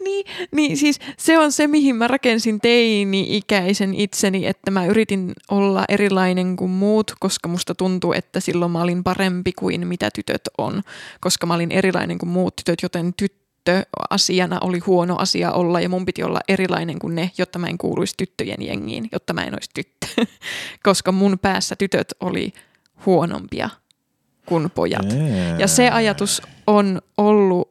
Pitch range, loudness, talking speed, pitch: 180-205 Hz, -19 LUFS, 160 wpm, 190 Hz